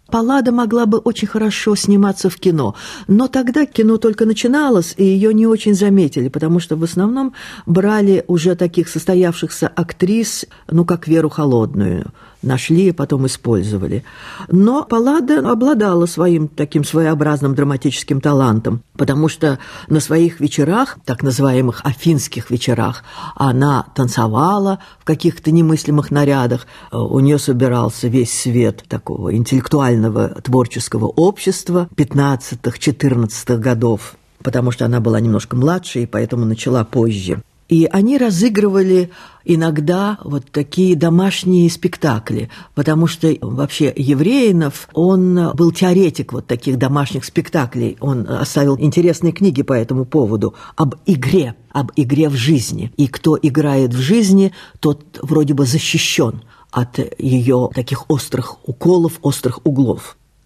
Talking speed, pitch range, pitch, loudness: 125 wpm, 130-180 Hz, 150 Hz, -15 LUFS